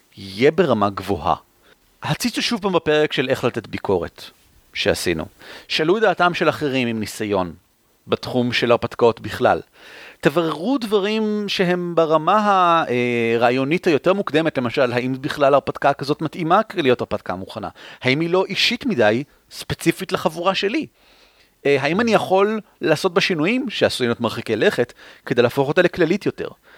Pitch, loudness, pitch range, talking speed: 150 Hz, -19 LUFS, 120-190 Hz, 140 wpm